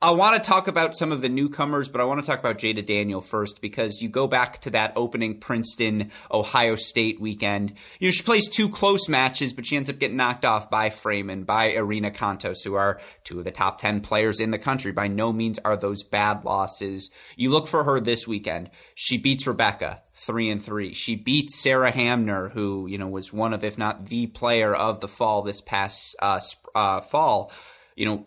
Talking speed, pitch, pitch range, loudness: 215 wpm, 110 Hz, 105-130 Hz, -24 LUFS